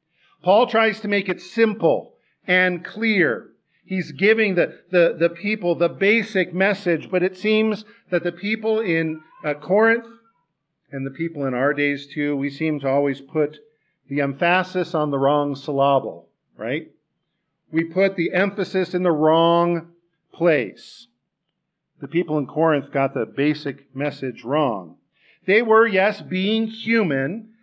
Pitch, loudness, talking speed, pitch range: 170 Hz, -21 LUFS, 145 wpm, 150-195 Hz